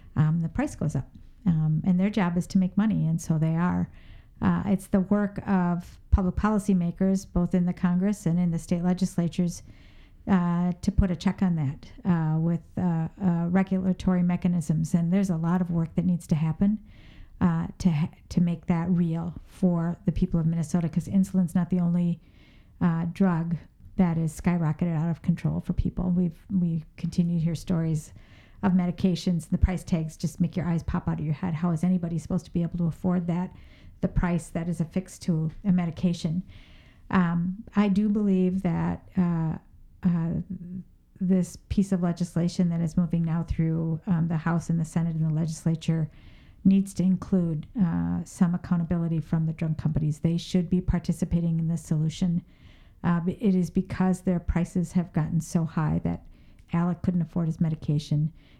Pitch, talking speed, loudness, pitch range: 175 Hz, 185 wpm, -27 LUFS, 165-185 Hz